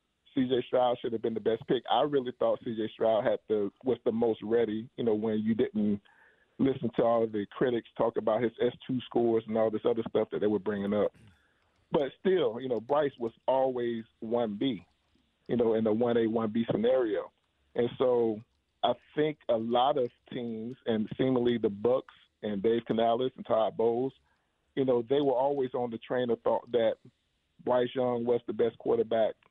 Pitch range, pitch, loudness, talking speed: 110-130 Hz, 120 Hz, -30 LUFS, 195 wpm